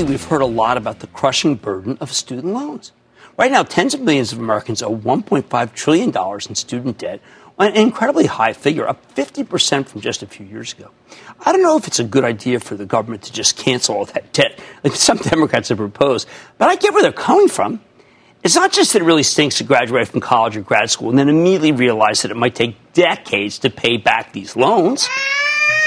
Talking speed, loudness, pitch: 215 wpm, -16 LUFS, 140 Hz